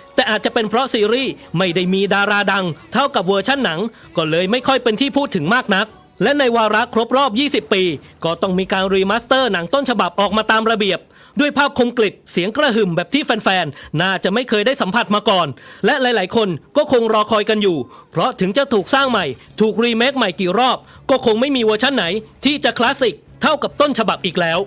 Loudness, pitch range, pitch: -16 LUFS, 190-255 Hz, 220 Hz